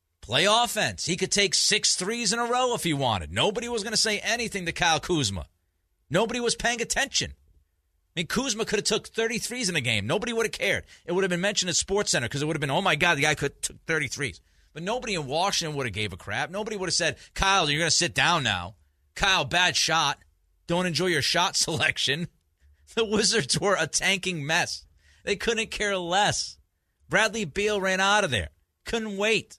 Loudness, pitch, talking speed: -25 LUFS, 175 Hz, 215 wpm